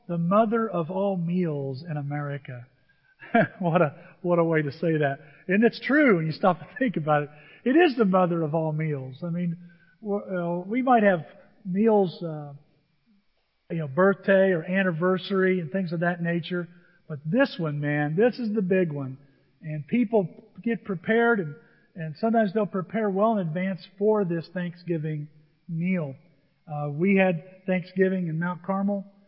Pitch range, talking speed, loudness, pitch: 155-200 Hz, 170 wpm, -25 LUFS, 180 Hz